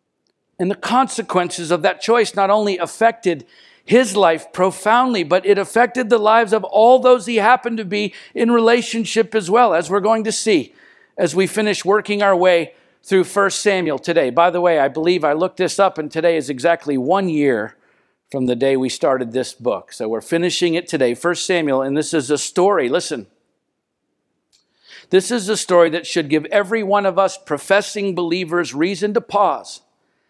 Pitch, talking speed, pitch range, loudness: 190 Hz, 185 wpm, 170-215 Hz, -17 LUFS